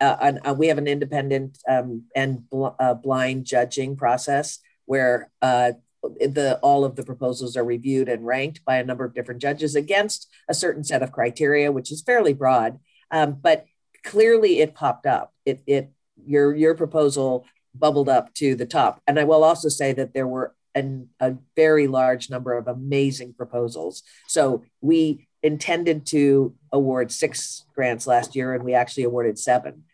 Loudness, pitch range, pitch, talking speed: -22 LUFS, 125-150 Hz, 135 Hz, 170 wpm